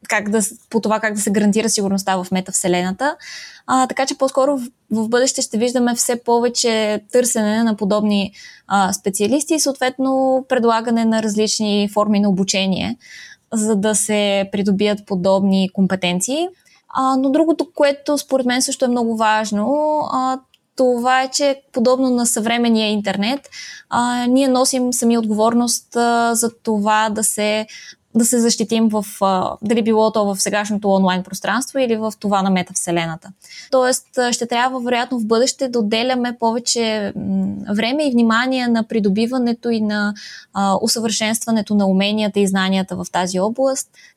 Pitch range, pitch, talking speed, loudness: 205-250 Hz, 225 Hz, 150 wpm, -17 LUFS